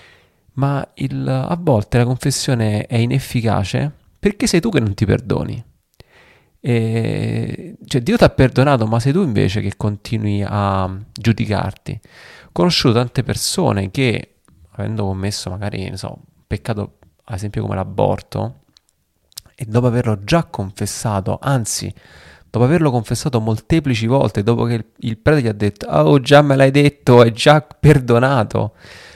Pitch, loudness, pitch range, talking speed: 115 Hz, -17 LUFS, 105-135 Hz, 145 wpm